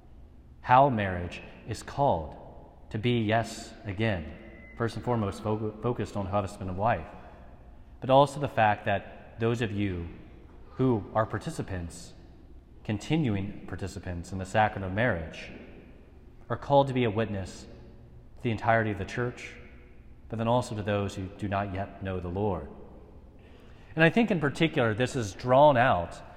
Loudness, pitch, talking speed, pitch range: -28 LUFS, 105 Hz, 155 wpm, 90-115 Hz